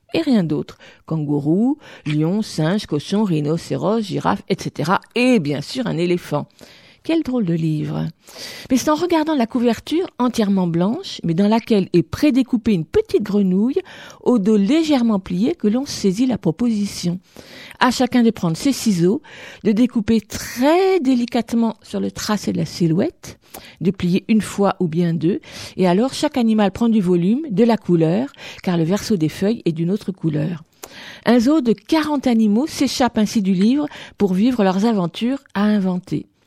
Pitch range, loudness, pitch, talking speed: 175-245 Hz, -19 LUFS, 215 Hz, 165 wpm